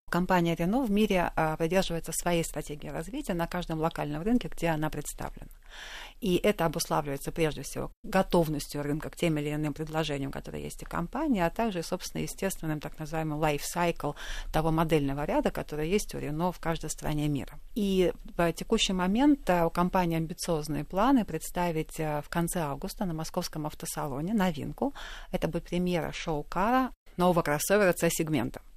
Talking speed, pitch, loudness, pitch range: 150 wpm, 165 Hz, -30 LUFS, 150-180 Hz